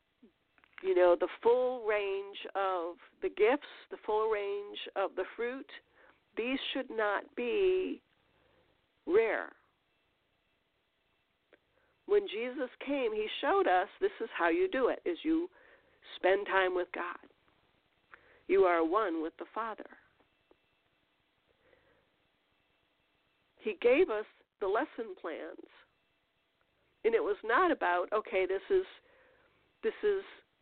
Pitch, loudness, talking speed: 345 Hz, -32 LUFS, 115 wpm